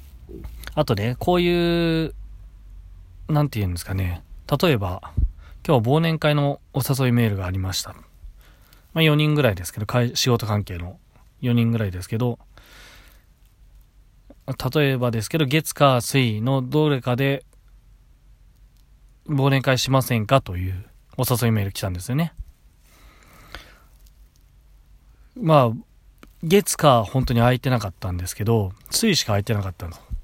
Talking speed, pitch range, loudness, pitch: 265 characters per minute, 95-140 Hz, -21 LUFS, 120 Hz